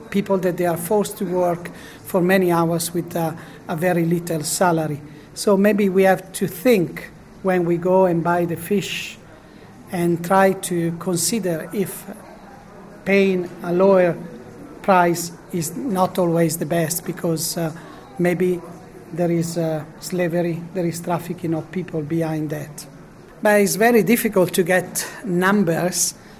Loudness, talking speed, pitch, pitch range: -20 LUFS, 145 wpm, 175 Hz, 170-190 Hz